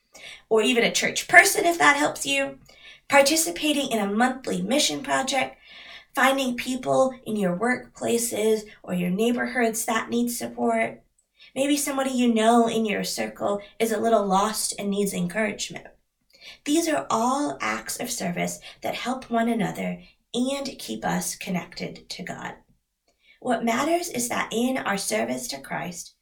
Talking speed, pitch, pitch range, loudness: 150 wpm, 230 Hz, 200-260 Hz, -24 LUFS